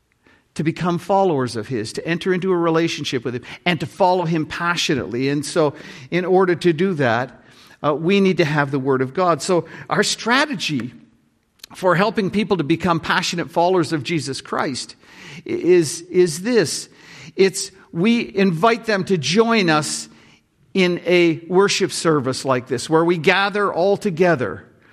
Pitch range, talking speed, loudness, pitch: 150-195 Hz, 160 wpm, -19 LUFS, 175 Hz